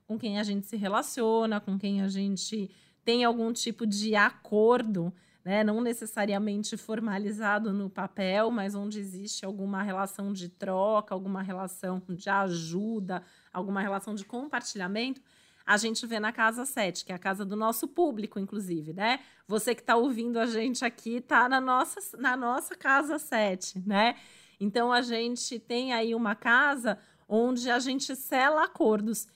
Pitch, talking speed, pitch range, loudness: 215 Hz, 160 wpm, 195-235 Hz, -29 LUFS